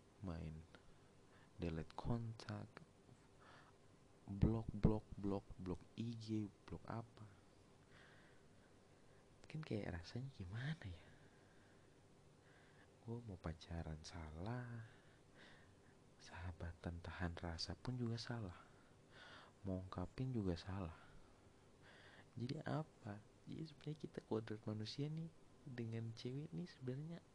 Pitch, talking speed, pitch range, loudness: 105 Hz, 90 wpm, 90-125 Hz, -49 LUFS